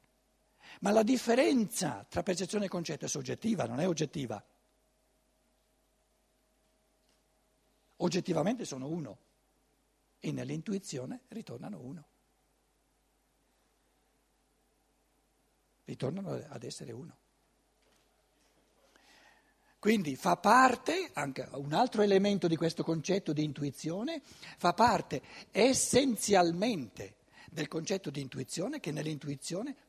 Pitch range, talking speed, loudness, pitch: 150-225 Hz, 90 wpm, -32 LUFS, 180 Hz